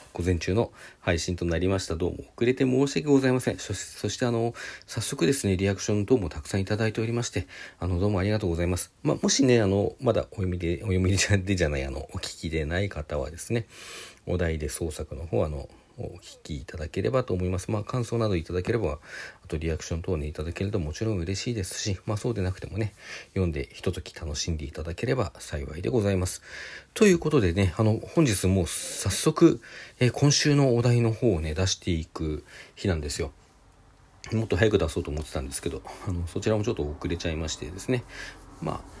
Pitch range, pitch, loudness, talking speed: 85-110 Hz, 95 Hz, -27 LUFS, 435 characters per minute